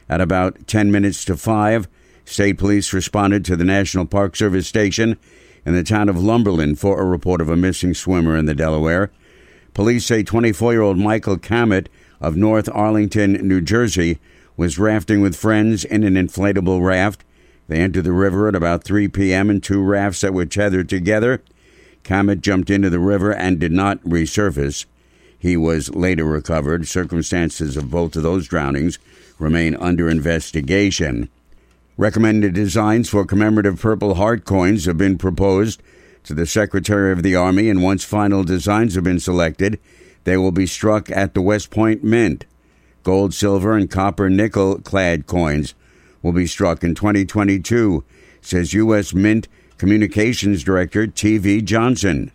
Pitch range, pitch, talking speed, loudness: 85-105 Hz, 95 Hz, 160 wpm, -17 LUFS